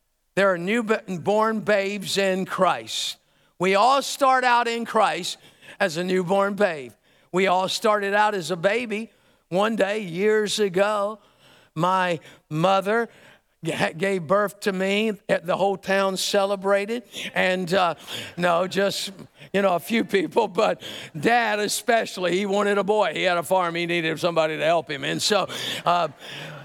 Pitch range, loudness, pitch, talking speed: 180-210 Hz, -23 LUFS, 195 Hz, 150 wpm